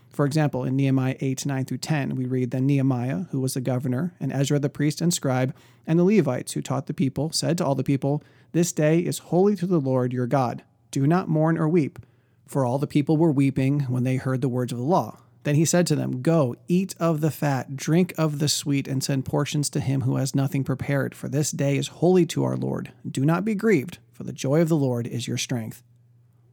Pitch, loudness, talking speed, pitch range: 140 Hz, -24 LUFS, 235 wpm, 130-155 Hz